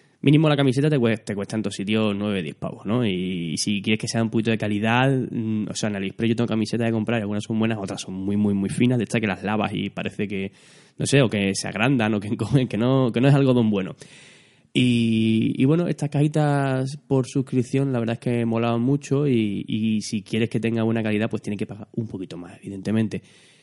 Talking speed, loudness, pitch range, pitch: 245 wpm, -23 LUFS, 105-130 Hz, 115 Hz